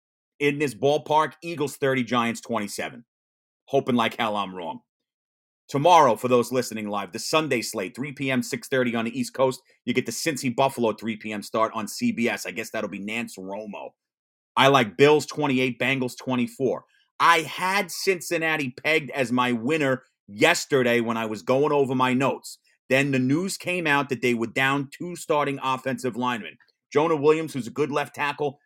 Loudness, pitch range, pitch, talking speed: -24 LUFS, 115-145 Hz, 130 Hz, 175 wpm